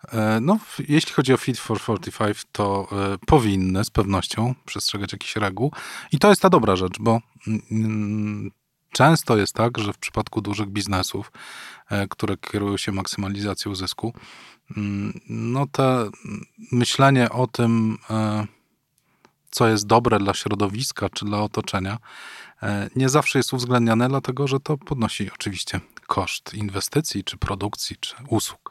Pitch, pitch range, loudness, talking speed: 110 Hz, 100-125 Hz, -22 LUFS, 145 wpm